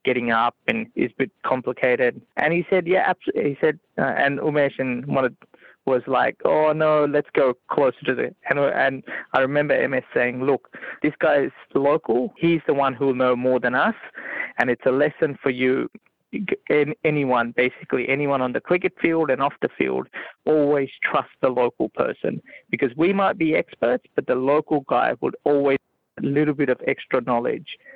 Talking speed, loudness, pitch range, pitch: 185 wpm, -22 LUFS, 130-160 Hz, 145 Hz